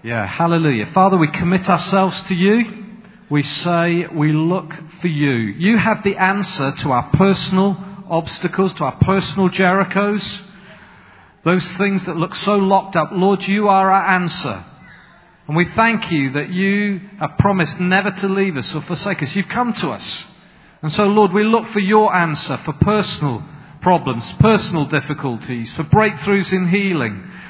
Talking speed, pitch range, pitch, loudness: 160 wpm, 155-195 Hz, 180 Hz, -16 LUFS